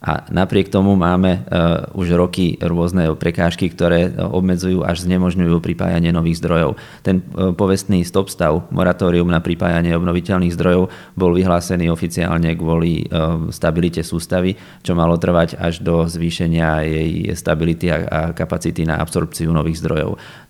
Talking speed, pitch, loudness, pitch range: 130 wpm, 85 Hz, -17 LUFS, 85-90 Hz